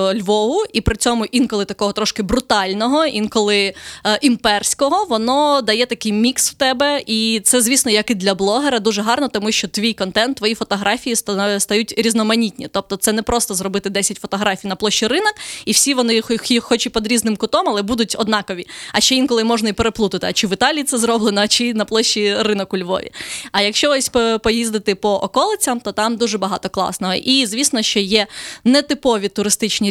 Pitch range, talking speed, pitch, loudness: 205-245 Hz, 185 wpm, 220 Hz, -16 LUFS